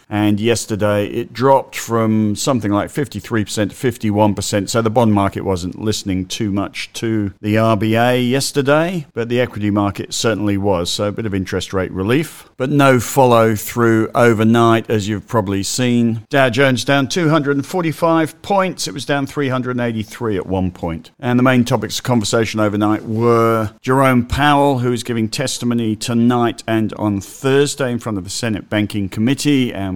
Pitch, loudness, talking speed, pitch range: 115 Hz, -16 LUFS, 165 wpm, 105-130 Hz